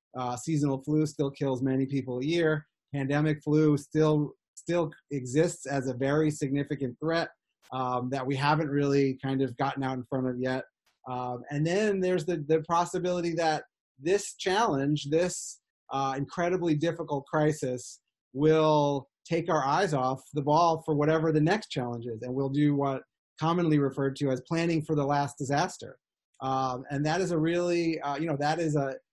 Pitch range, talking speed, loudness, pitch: 135-160 Hz, 175 wpm, -29 LUFS, 145 Hz